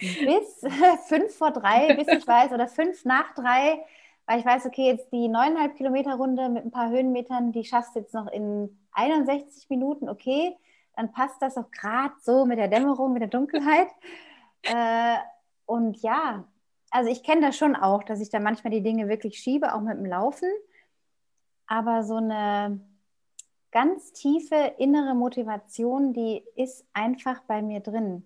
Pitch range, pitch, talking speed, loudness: 225-290 Hz, 255 Hz, 165 wpm, -25 LUFS